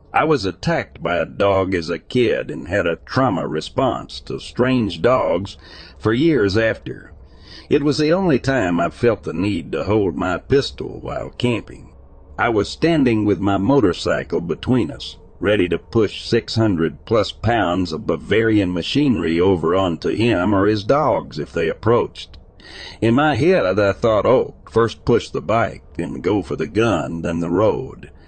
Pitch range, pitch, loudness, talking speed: 85-115 Hz, 100 Hz, -19 LUFS, 170 wpm